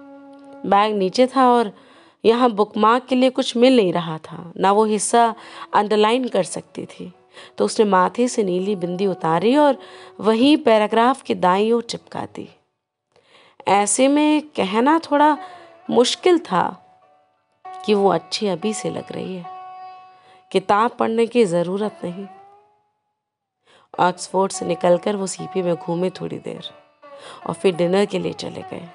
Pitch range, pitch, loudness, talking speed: 190-275 Hz, 225 Hz, -19 LUFS, 145 wpm